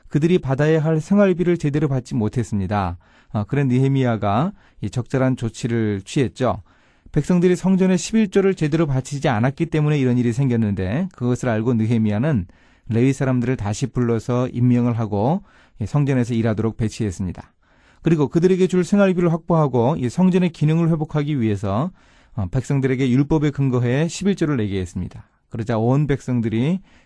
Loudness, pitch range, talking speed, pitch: -20 LUFS, 115-160 Hz, 365 characters per minute, 130 Hz